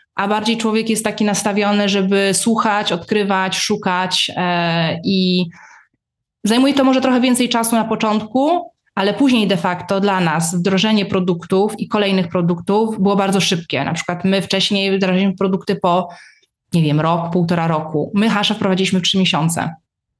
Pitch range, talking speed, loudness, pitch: 180-210 Hz, 150 wpm, -16 LUFS, 195 Hz